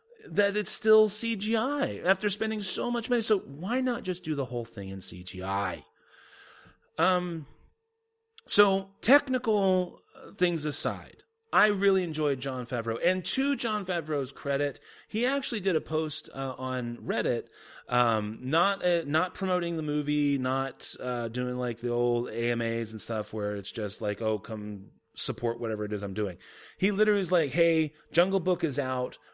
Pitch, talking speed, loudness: 155 Hz, 160 wpm, -29 LUFS